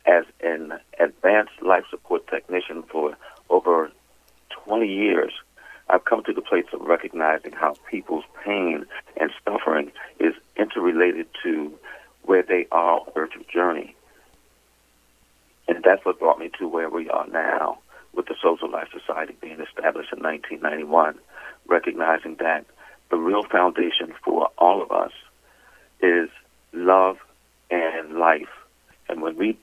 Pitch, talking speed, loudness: 90 Hz, 135 wpm, -23 LUFS